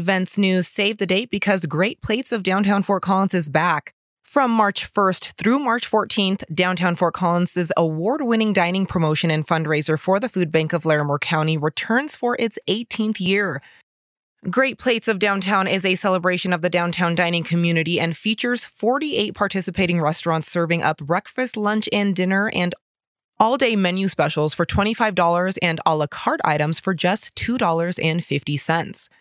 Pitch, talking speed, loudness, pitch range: 185 Hz, 160 wpm, -20 LUFS, 170-210 Hz